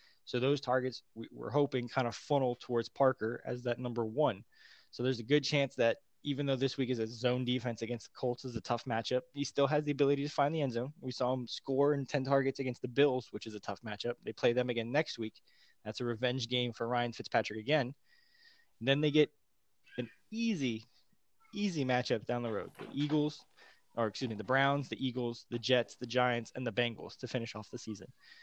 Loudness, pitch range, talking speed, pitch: -34 LUFS, 120-140 Hz, 225 wpm, 125 Hz